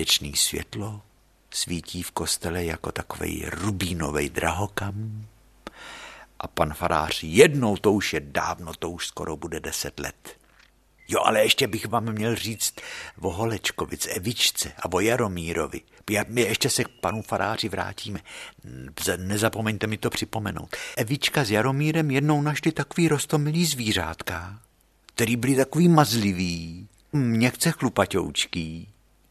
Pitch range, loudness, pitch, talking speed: 90-120 Hz, -25 LUFS, 110 Hz, 125 wpm